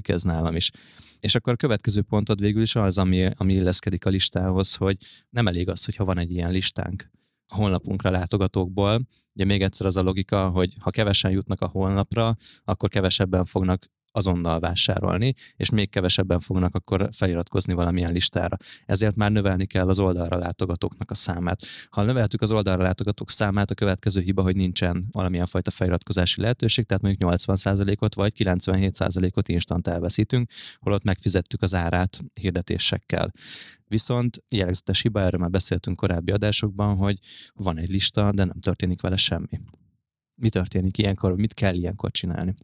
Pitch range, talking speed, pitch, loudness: 90-105 Hz, 160 wpm, 95 Hz, -24 LUFS